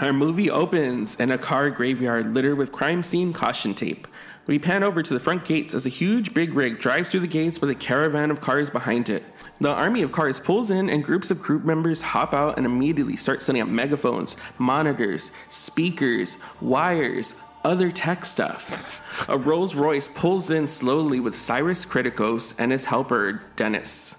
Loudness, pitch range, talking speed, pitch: -23 LUFS, 130-170 Hz, 185 wpm, 150 Hz